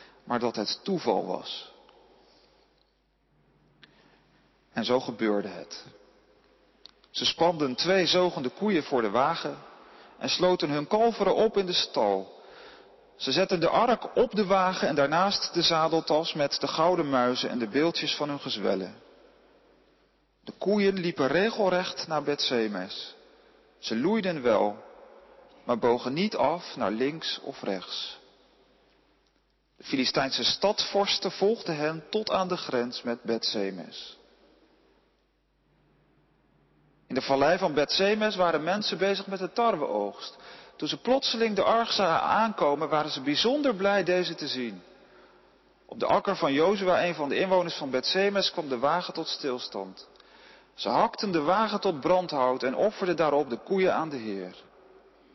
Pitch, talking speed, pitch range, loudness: 180 Hz, 140 wpm, 145-200 Hz, -27 LUFS